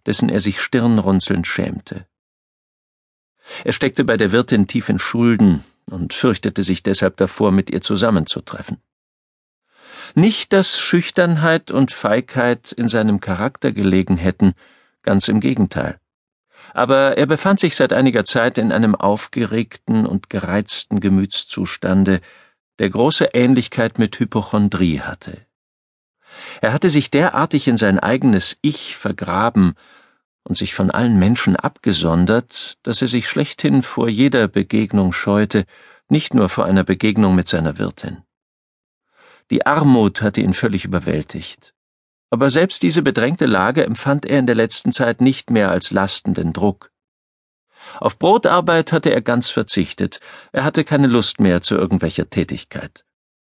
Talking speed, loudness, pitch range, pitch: 135 wpm, -17 LUFS, 95-135 Hz, 110 Hz